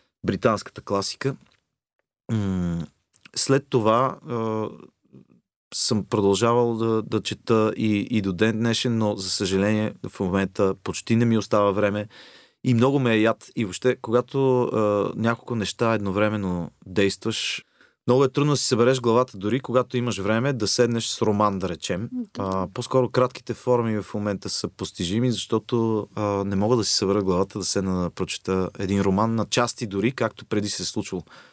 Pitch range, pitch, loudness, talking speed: 100-120 Hz, 110 Hz, -24 LUFS, 155 wpm